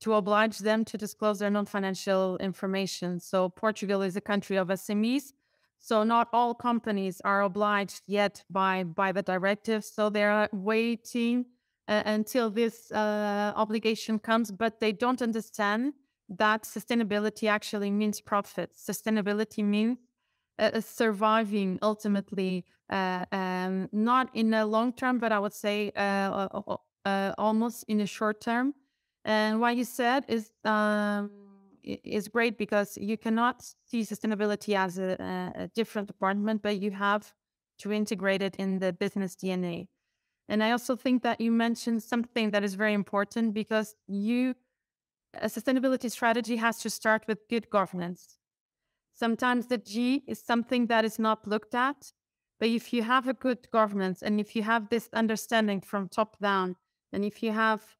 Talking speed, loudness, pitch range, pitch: 155 wpm, -29 LUFS, 200-230 Hz, 215 Hz